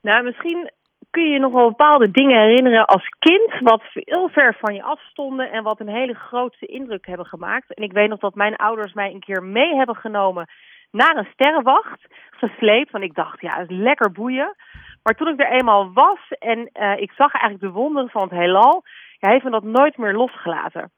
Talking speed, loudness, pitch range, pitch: 215 wpm, -17 LUFS, 210-280 Hz, 230 Hz